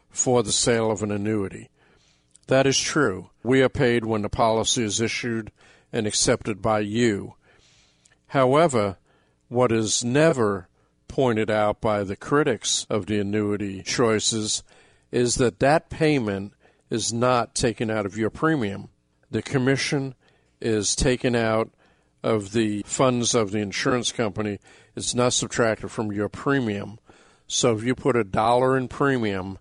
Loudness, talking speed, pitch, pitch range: -23 LUFS, 145 wpm, 110 Hz, 105-125 Hz